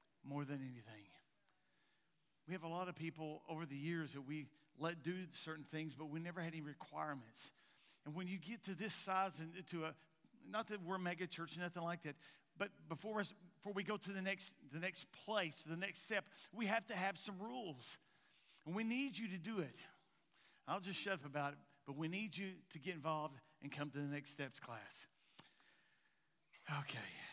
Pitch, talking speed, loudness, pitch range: 170 Hz, 200 wpm, -47 LUFS, 150-195 Hz